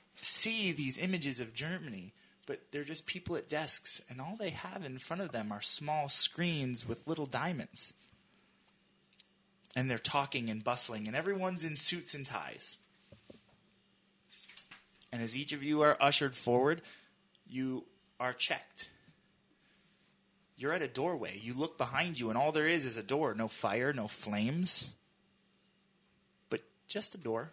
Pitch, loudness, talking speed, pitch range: 150 Hz, -33 LUFS, 155 wpm, 125-185 Hz